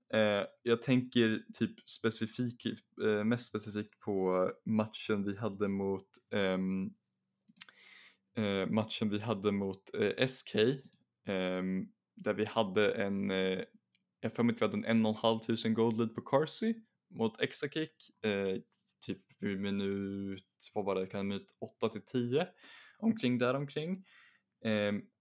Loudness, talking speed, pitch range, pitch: -35 LUFS, 105 wpm, 100-115 Hz, 110 Hz